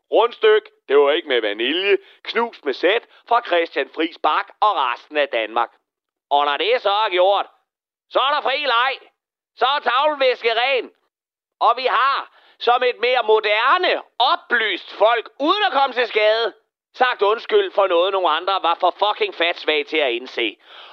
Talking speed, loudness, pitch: 170 wpm, -19 LUFS, 240 Hz